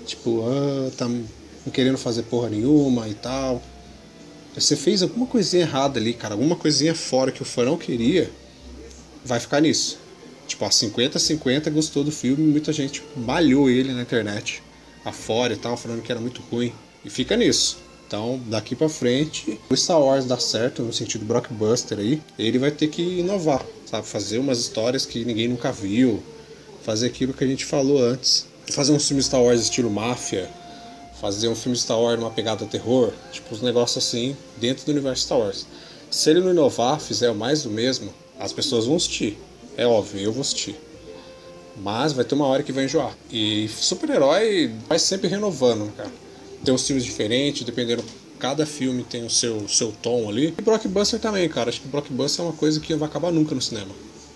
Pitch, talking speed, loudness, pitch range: 130 Hz, 190 wpm, -22 LUFS, 115-150 Hz